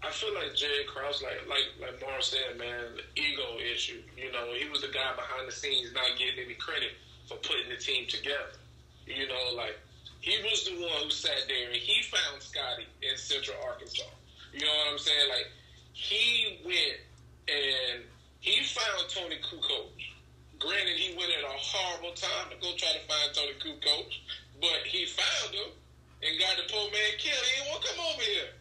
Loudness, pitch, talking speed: -30 LUFS, 145 Hz, 190 wpm